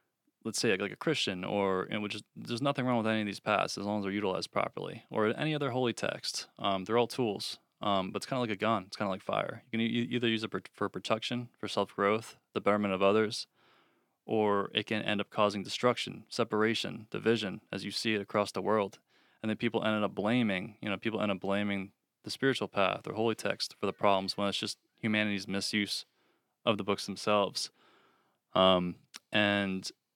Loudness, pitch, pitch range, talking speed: -32 LUFS, 105 Hz, 100-115 Hz, 215 wpm